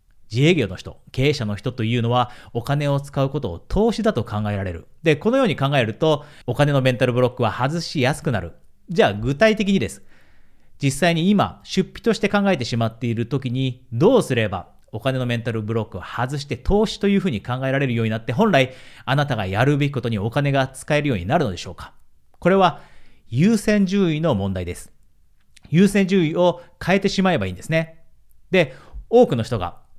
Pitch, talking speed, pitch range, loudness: 135 Hz, 390 characters per minute, 115-170 Hz, -20 LUFS